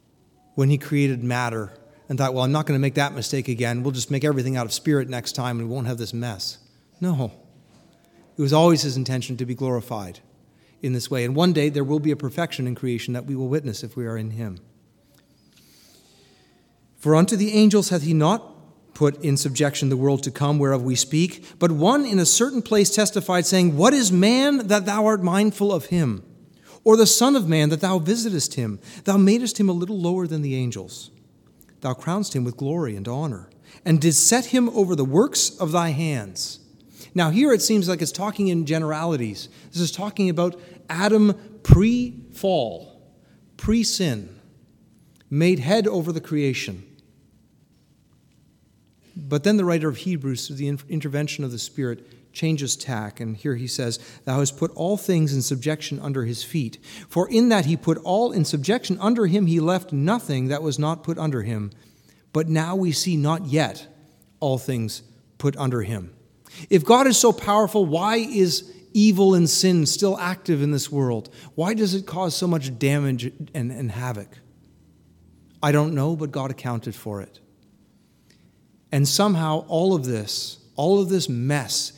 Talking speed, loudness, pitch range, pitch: 185 wpm, -22 LUFS, 130-185 Hz, 150 Hz